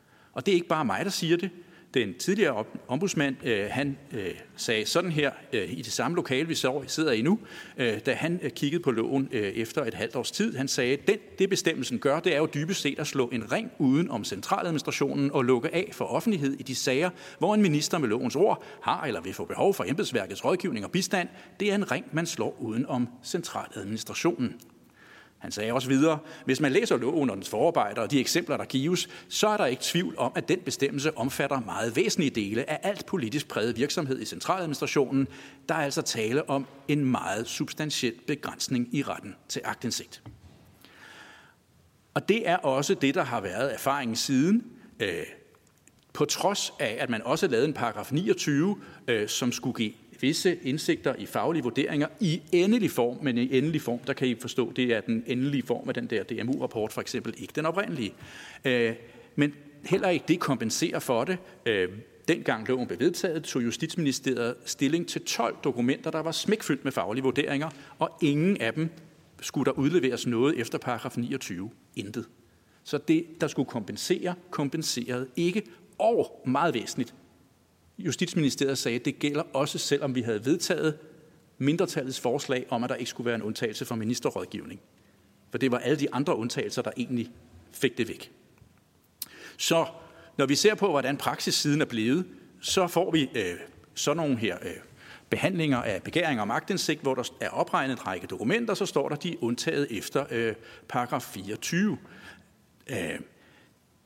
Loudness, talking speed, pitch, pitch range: -28 LUFS, 180 wpm, 140 Hz, 125-165 Hz